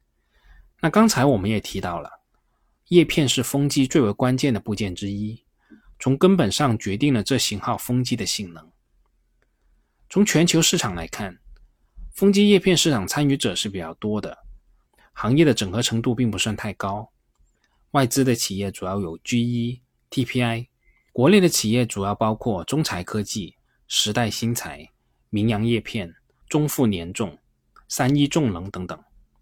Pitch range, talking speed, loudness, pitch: 105-140 Hz, 235 characters per minute, -22 LUFS, 120 Hz